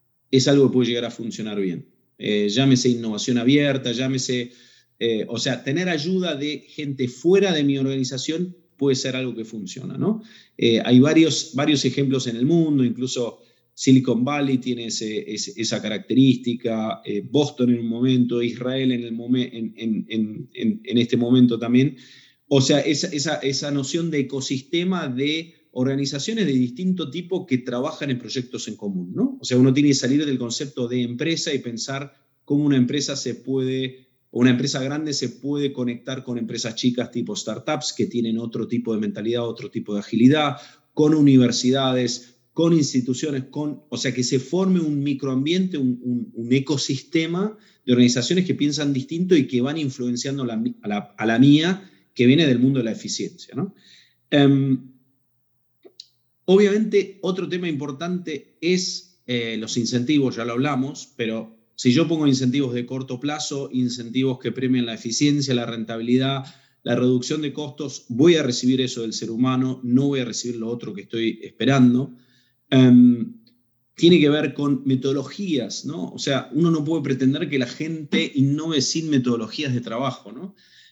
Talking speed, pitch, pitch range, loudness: 170 wpm, 130 Hz, 120-145 Hz, -21 LUFS